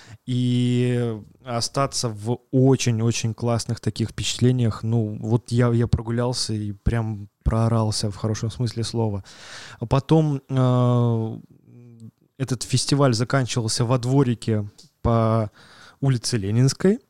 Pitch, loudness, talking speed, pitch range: 120 Hz, -23 LUFS, 110 wpm, 110-125 Hz